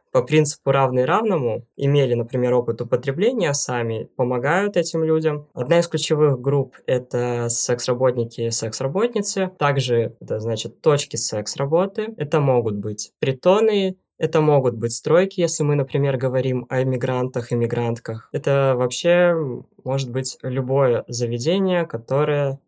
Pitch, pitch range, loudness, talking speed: 135 Hz, 120-155 Hz, -21 LUFS, 125 wpm